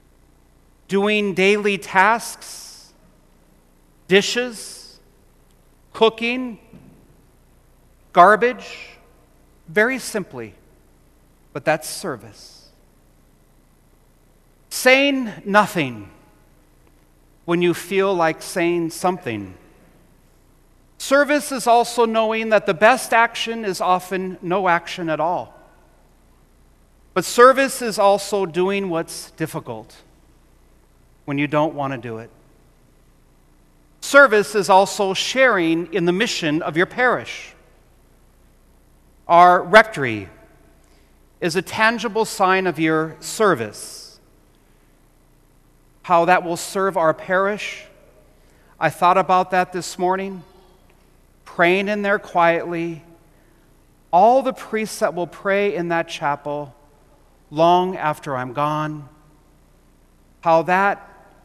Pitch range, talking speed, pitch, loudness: 160-205 Hz, 95 wpm, 180 Hz, -18 LUFS